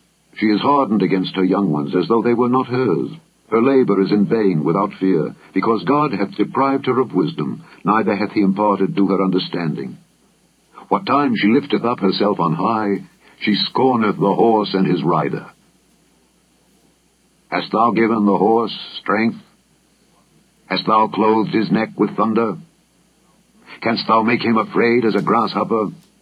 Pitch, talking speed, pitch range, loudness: 105 Hz, 160 wpm, 95-115 Hz, -17 LUFS